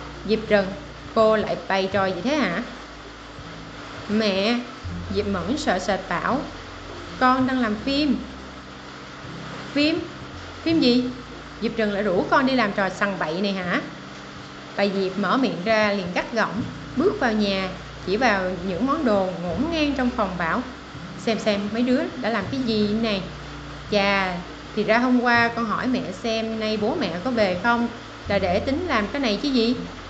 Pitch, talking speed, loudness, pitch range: 215 Hz, 175 wpm, -23 LUFS, 190-250 Hz